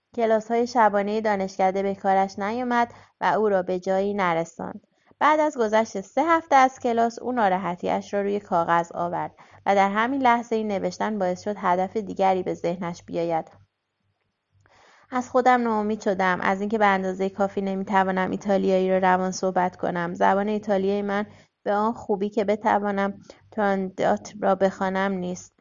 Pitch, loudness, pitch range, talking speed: 195 Hz, -24 LUFS, 185-220 Hz, 155 wpm